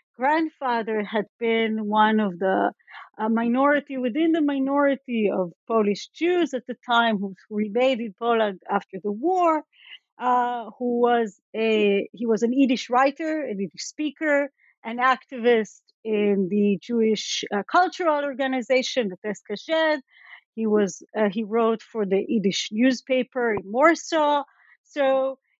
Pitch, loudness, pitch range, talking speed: 235 Hz, -23 LUFS, 215-275 Hz, 135 wpm